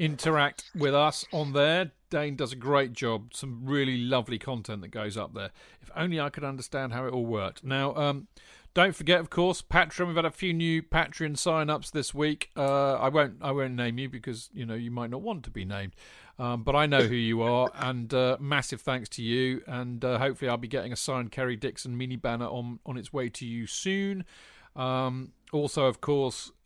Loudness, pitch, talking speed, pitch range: -29 LUFS, 135 Hz, 215 wpm, 120-150 Hz